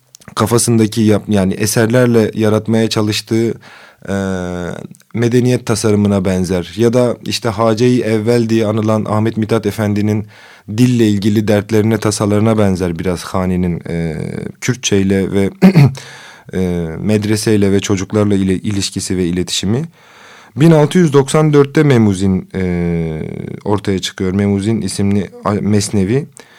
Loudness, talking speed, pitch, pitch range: -14 LUFS, 105 wpm, 105 Hz, 95-115 Hz